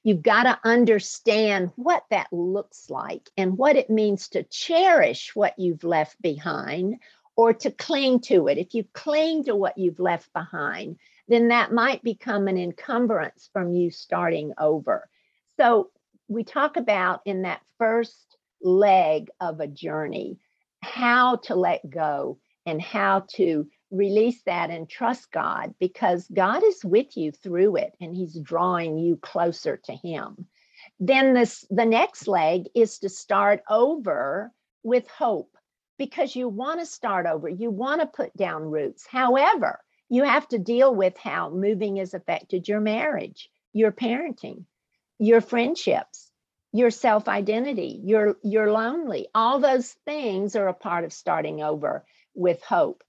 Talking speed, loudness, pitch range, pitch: 150 wpm, -23 LUFS, 185-250 Hz, 215 Hz